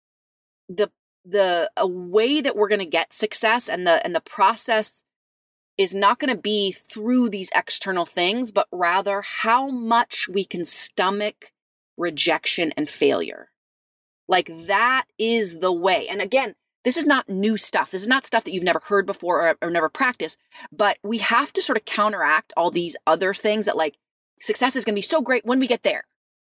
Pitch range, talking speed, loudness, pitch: 185-245 Hz, 180 wpm, -21 LUFS, 210 Hz